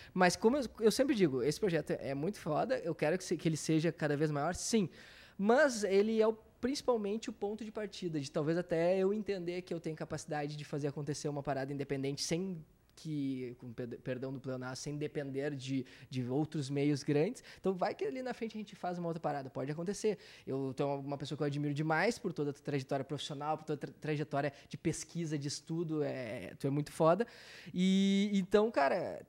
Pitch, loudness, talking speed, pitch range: 160 Hz, -35 LUFS, 210 wpm, 145-195 Hz